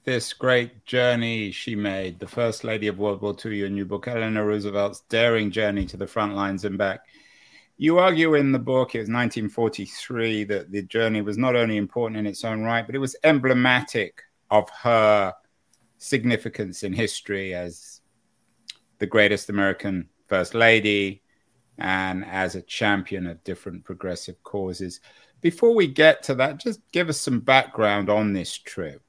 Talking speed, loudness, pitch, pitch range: 165 wpm, -23 LUFS, 110 Hz, 100-120 Hz